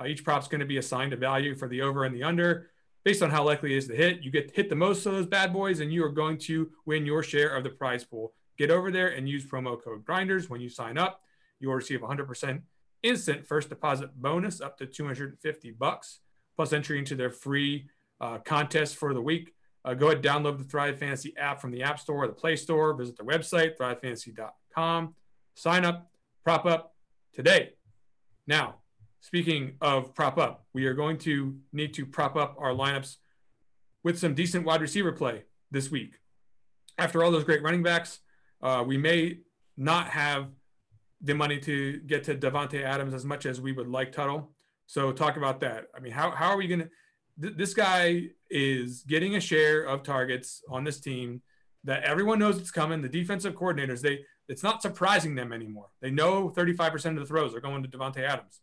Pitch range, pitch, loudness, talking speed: 135-165 Hz, 150 Hz, -29 LUFS, 205 wpm